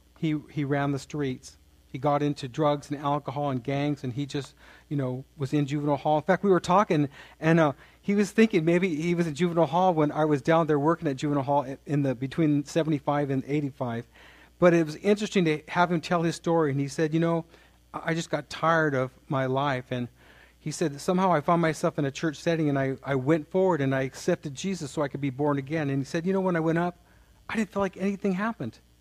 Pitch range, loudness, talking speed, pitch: 140-170 Hz, -27 LUFS, 240 wpm, 150 Hz